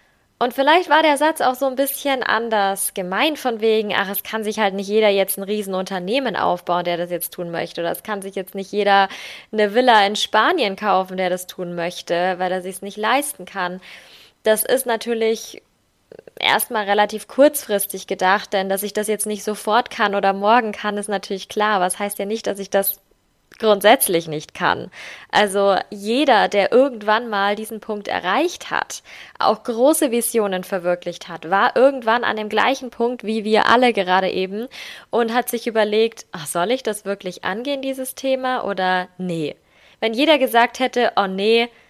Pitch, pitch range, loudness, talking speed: 210 Hz, 195-235 Hz, -19 LUFS, 185 wpm